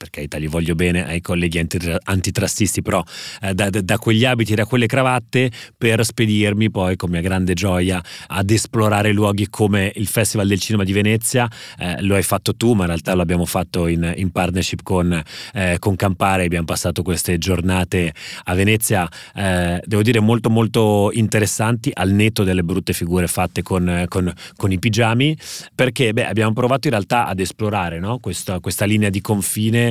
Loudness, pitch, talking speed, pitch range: -18 LUFS, 100 Hz, 180 wpm, 90-110 Hz